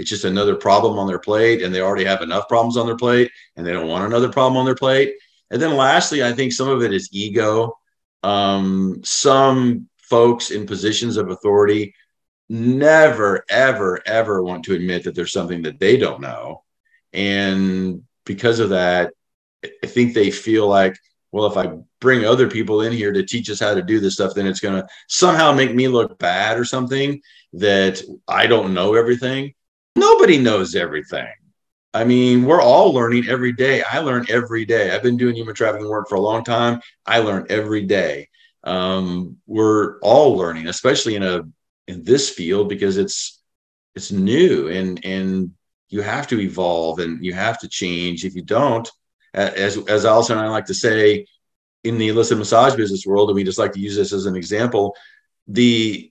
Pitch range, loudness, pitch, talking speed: 95-120 Hz, -17 LUFS, 110 Hz, 190 wpm